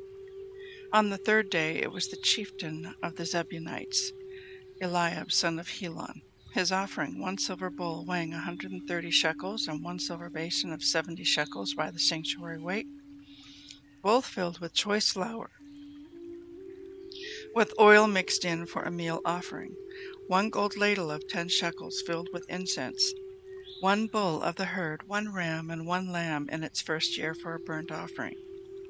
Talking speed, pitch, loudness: 155 wpm, 185 Hz, -30 LUFS